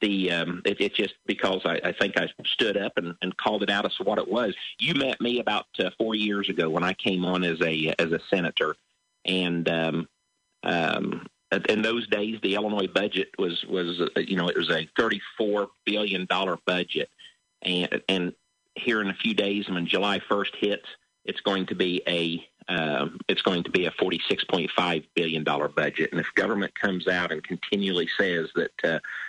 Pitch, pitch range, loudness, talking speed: 95 Hz, 85-105 Hz, -26 LUFS, 200 wpm